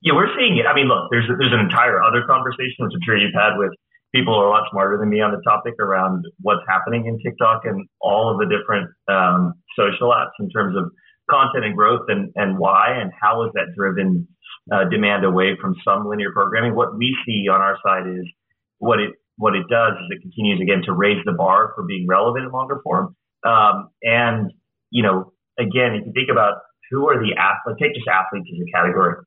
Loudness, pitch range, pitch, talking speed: -18 LUFS, 95-120 Hz, 105 Hz, 225 wpm